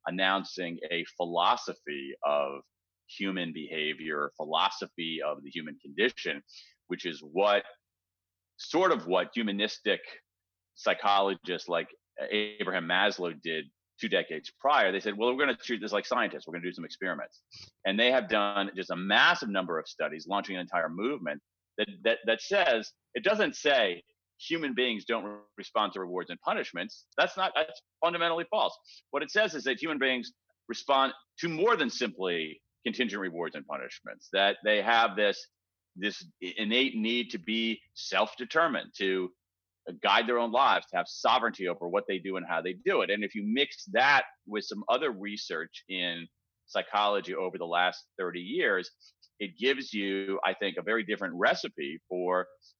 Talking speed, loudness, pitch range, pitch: 165 wpm, -30 LUFS, 90-115 Hz, 100 Hz